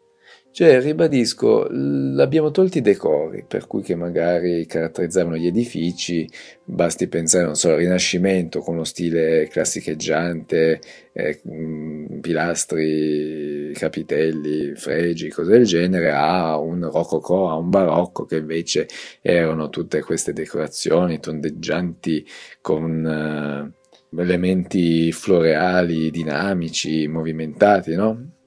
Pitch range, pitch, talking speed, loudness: 80-90 Hz, 85 Hz, 105 wpm, -20 LUFS